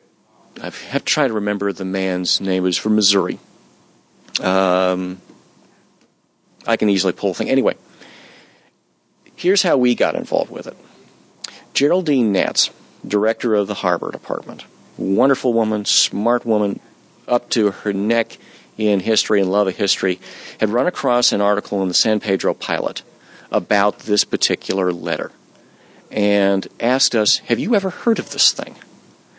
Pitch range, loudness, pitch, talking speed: 95-115 Hz, -18 LUFS, 105 Hz, 150 wpm